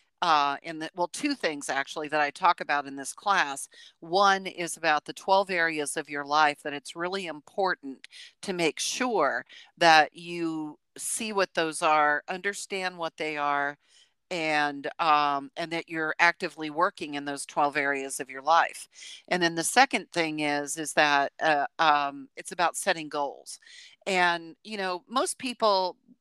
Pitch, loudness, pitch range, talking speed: 165 Hz, -27 LUFS, 150-180 Hz, 165 wpm